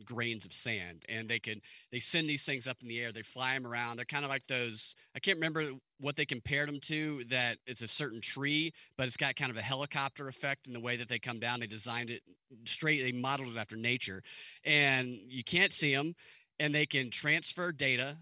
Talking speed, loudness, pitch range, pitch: 230 wpm, -33 LUFS, 120-145 Hz, 130 Hz